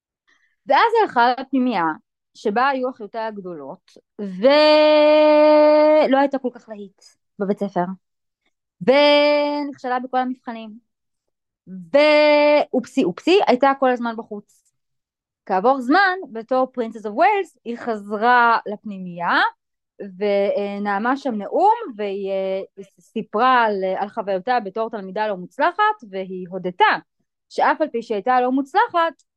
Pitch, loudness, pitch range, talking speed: 240 Hz, -18 LUFS, 205-290 Hz, 105 wpm